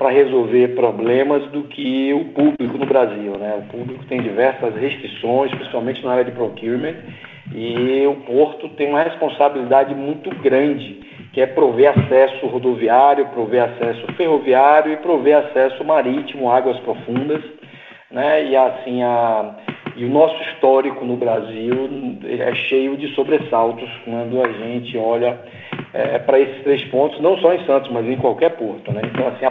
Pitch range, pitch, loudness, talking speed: 120-145 Hz, 130 Hz, -17 LUFS, 155 wpm